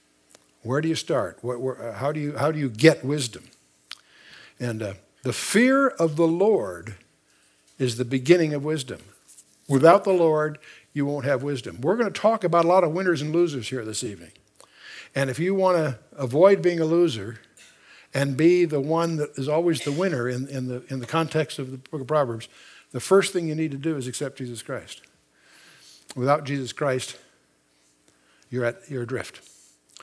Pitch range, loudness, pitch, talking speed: 125-165 Hz, -24 LUFS, 140 Hz, 190 wpm